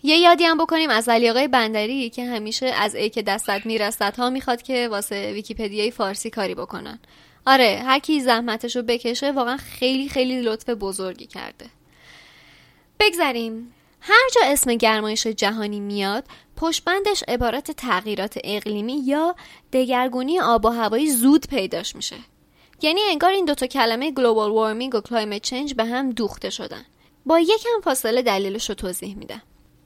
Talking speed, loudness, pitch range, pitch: 150 wpm, -21 LUFS, 215-275 Hz, 240 Hz